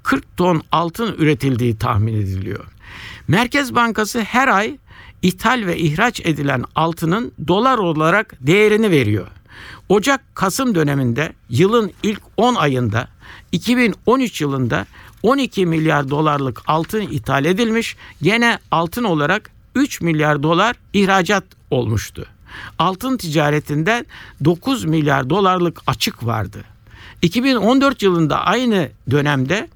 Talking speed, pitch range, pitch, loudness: 105 wpm, 130-215 Hz, 165 Hz, -17 LUFS